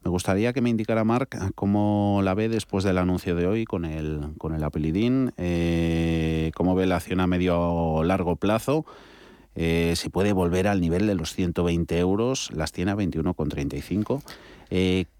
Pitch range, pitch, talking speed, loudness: 85-100 Hz, 90 Hz, 175 wpm, -25 LUFS